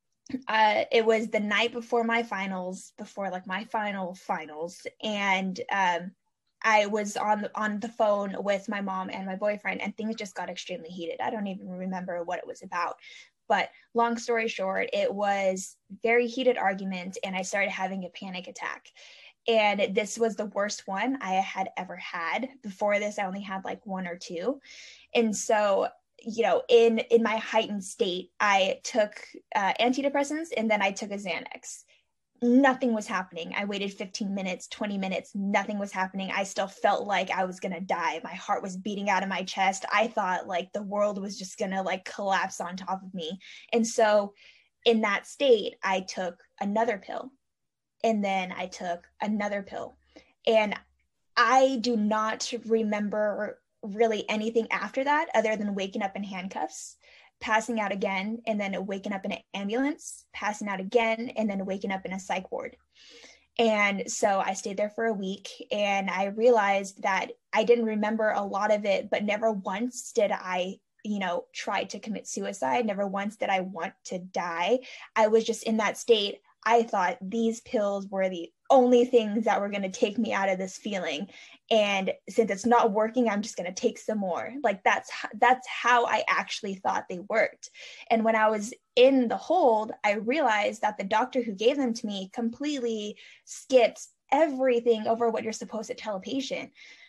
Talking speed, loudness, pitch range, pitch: 185 wpm, -28 LUFS, 195-230 Hz, 210 Hz